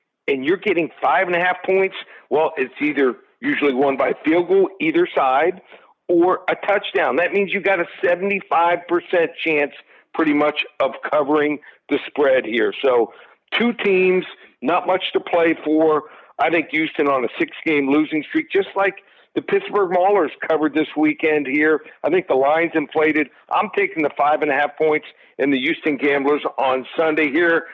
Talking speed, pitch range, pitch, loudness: 175 wpm, 150-205 Hz, 170 Hz, -19 LUFS